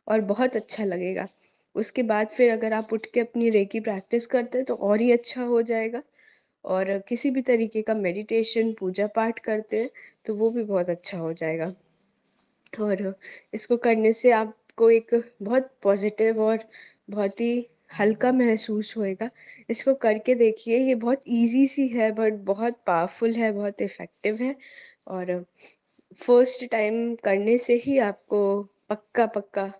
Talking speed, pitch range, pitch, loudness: 155 wpm, 205-240 Hz, 225 Hz, -25 LUFS